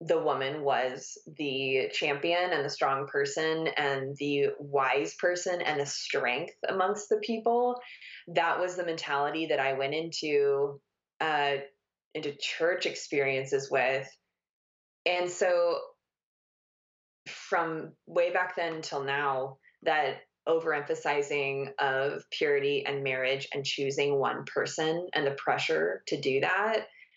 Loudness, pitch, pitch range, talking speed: -30 LUFS, 155 Hz, 140-185 Hz, 125 wpm